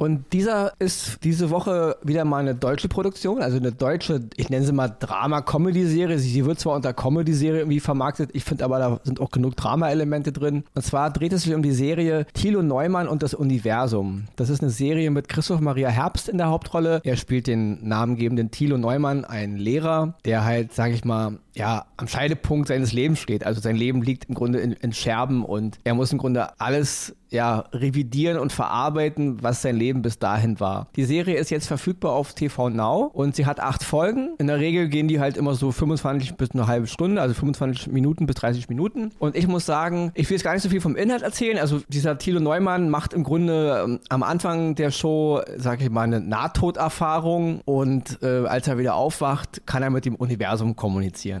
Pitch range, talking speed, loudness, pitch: 125-160 Hz, 205 wpm, -23 LUFS, 140 Hz